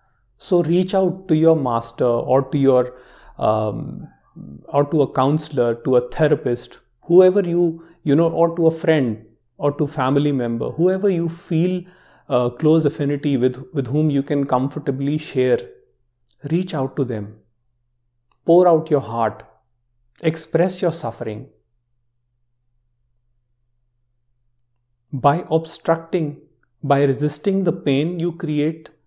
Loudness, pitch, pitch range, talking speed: -19 LUFS, 140 Hz, 120-165 Hz, 125 wpm